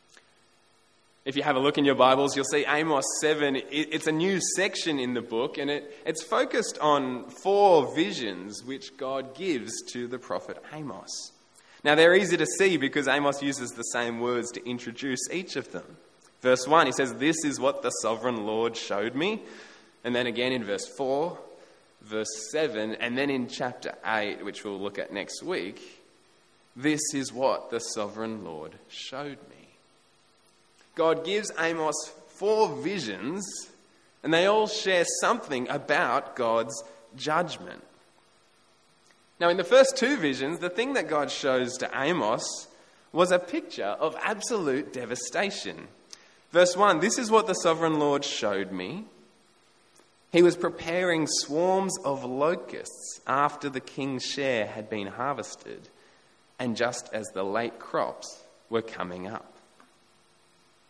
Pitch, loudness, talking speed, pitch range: 140 Hz, -27 LUFS, 150 wpm, 115-165 Hz